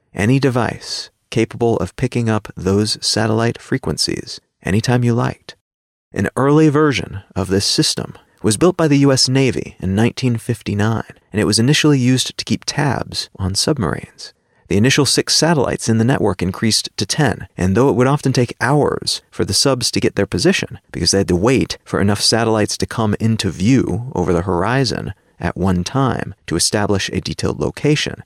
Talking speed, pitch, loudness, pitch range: 175 wpm, 115 Hz, -17 LUFS, 95-130 Hz